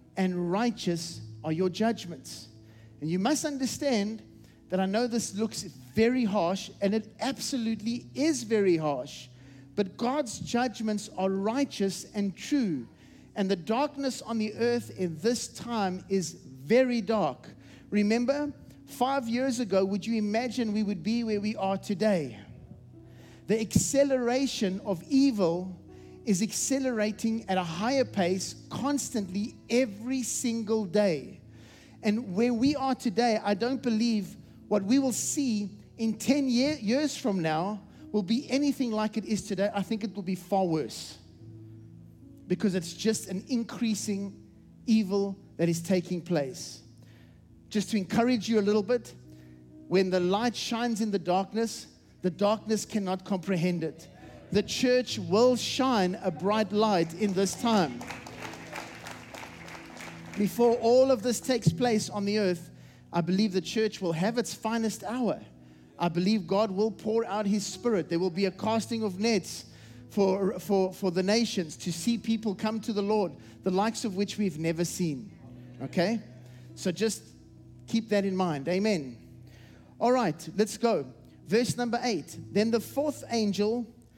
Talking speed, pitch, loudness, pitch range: 150 wpm, 205 Hz, -29 LUFS, 175-230 Hz